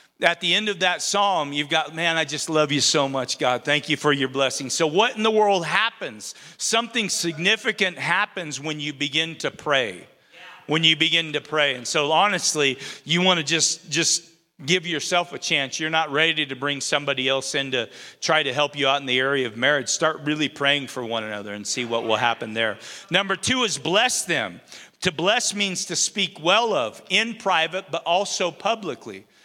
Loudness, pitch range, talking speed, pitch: -22 LUFS, 140-180 Hz, 205 wpm, 155 Hz